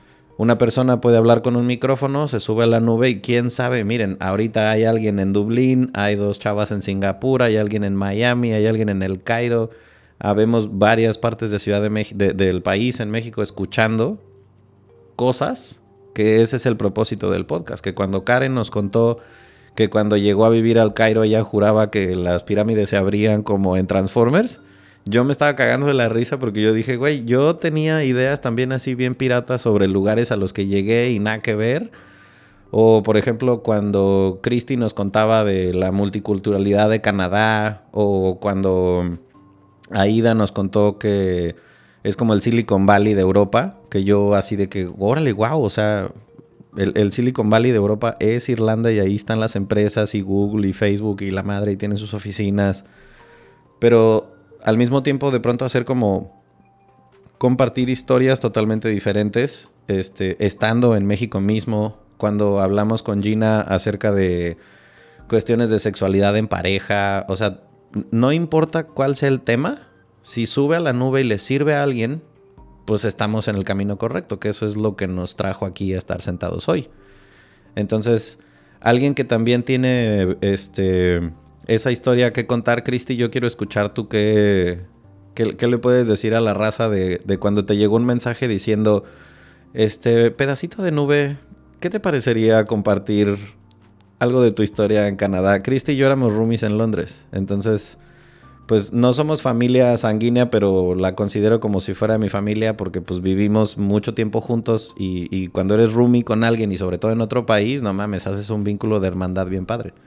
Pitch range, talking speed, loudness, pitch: 100-120 Hz, 175 wpm, -19 LUFS, 110 Hz